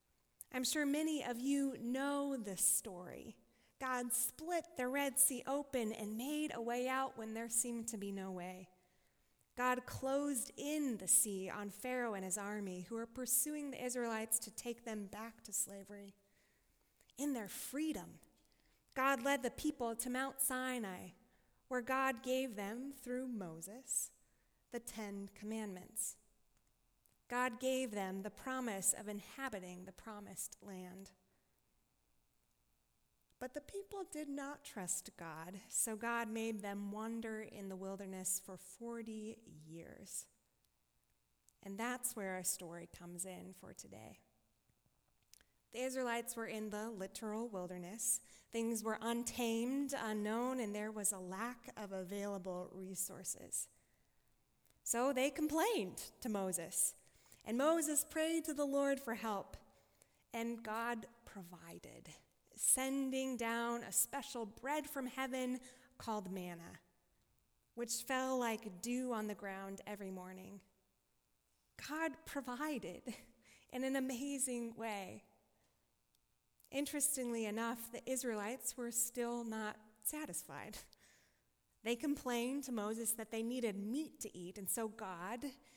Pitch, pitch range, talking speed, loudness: 230 Hz, 200-260 Hz, 130 wpm, -41 LUFS